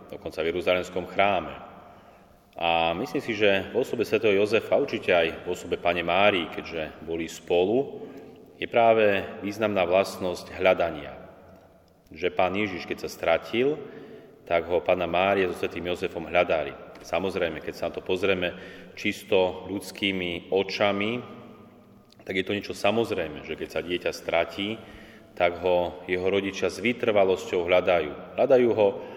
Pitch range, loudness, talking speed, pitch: 90-100 Hz, -26 LUFS, 140 wpm, 95 Hz